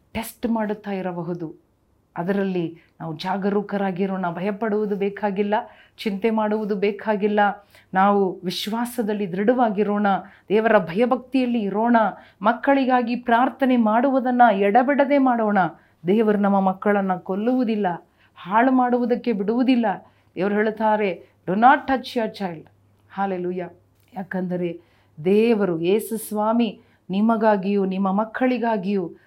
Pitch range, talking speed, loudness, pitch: 190-230 Hz, 90 wpm, -21 LUFS, 210 Hz